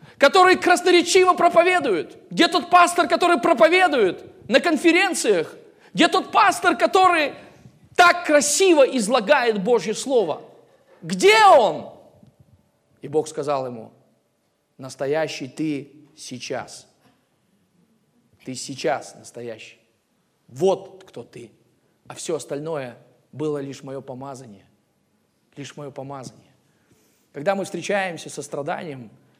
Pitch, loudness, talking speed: 235 Hz, -19 LUFS, 100 wpm